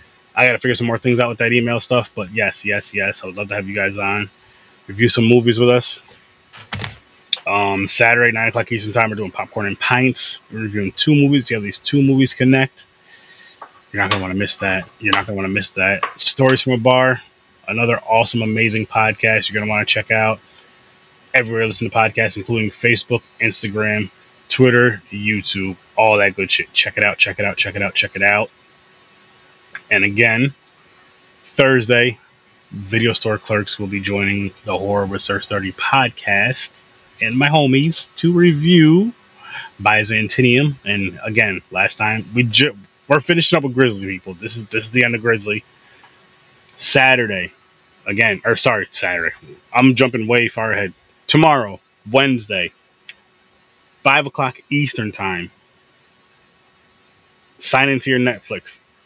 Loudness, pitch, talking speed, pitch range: -16 LUFS, 115 Hz, 170 wpm, 105-125 Hz